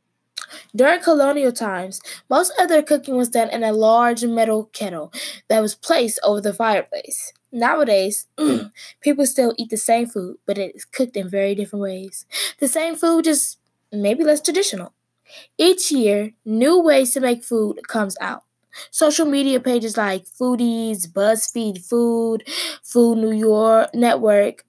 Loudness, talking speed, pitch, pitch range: -18 LUFS, 150 wpm, 230 Hz, 215-280 Hz